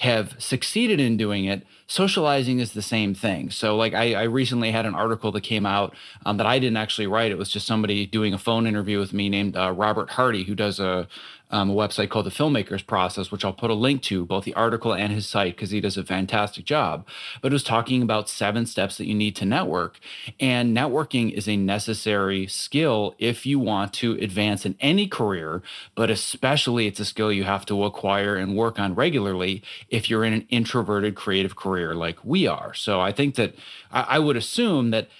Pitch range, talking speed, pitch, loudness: 100-115 Hz, 215 wpm, 105 Hz, -23 LUFS